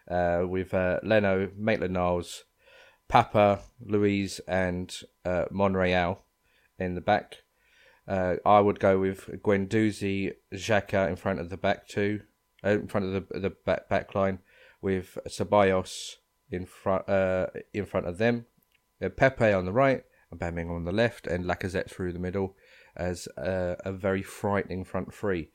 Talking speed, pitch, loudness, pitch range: 155 wpm, 95 Hz, -28 LUFS, 90-100 Hz